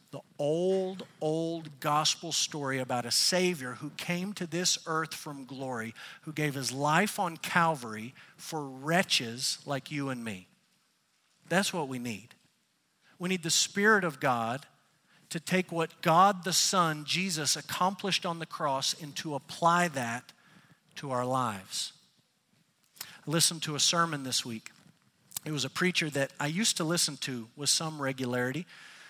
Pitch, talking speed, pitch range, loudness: 155 Hz, 155 wpm, 135-175 Hz, -30 LUFS